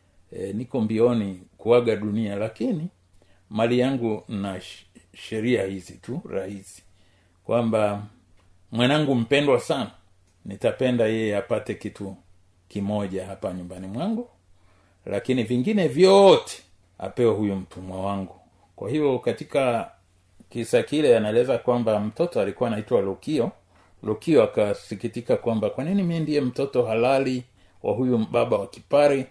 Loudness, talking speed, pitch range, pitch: -24 LUFS, 115 wpm, 95-125 Hz, 105 Hz